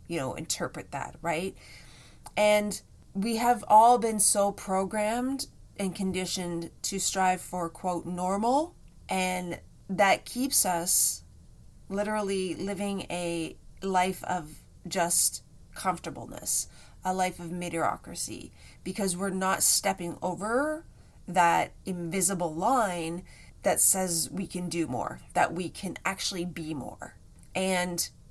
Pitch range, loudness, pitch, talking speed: 175-200 Hz, -27 LUFS, 185 Hz, 115 wpm